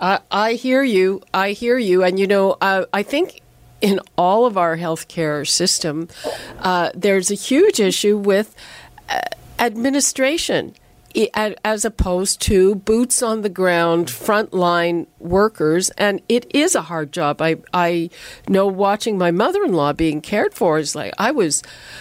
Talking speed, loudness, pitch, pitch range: 145 wpm, -18 LUFS, 195 Hz, 170-220 Hz